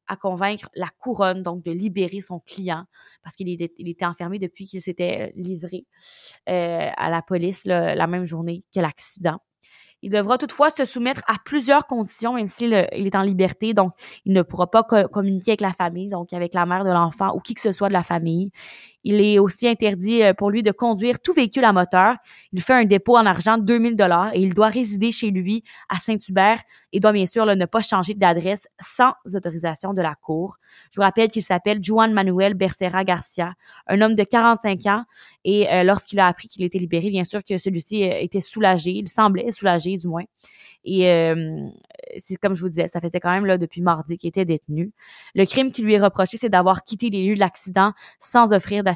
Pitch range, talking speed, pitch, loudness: 180-215 Hz, 215 wpm, 195 Hz, -20 LUFS